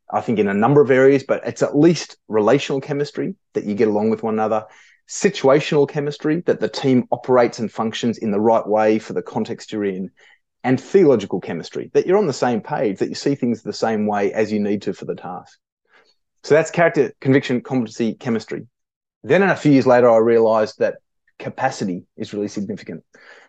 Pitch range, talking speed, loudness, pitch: 110-140 Hz, 200 wpm, -19 LUFS, 120 Hz